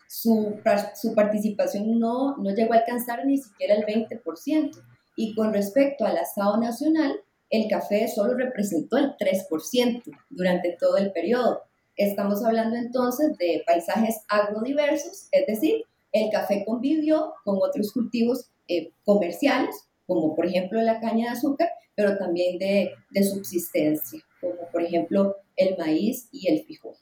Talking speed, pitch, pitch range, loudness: 140 wpm, 220 Hz, 195-255 Hz, -25 LUFS